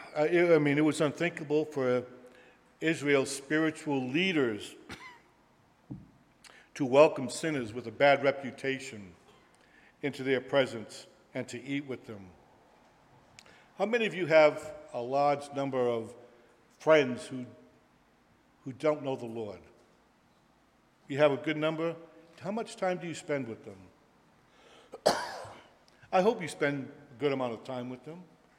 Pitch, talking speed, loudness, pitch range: 140 Hz, 135 wpm, -30 LUFS, 125-155 Hz